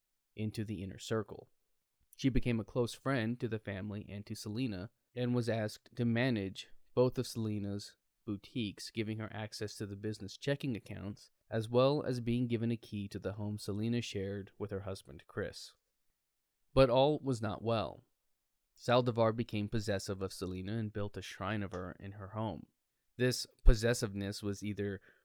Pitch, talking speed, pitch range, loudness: 110 Hz, 170 wpm, 100-120 Hz, -37 LUFS